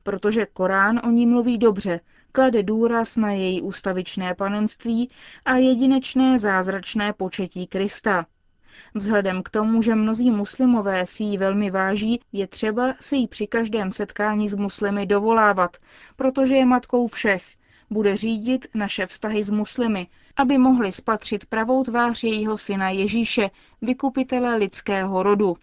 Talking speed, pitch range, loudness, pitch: 135 wpm, 195-240 Hz, -22 LUFS, 215 Hz